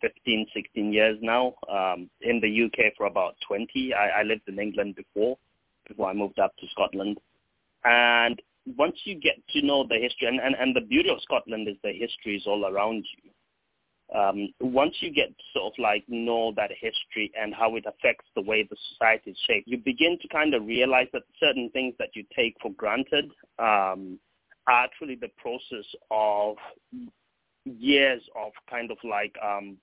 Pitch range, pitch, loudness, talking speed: 105-130 Hz, 115 Hz, -26 LUFS, 185 wpm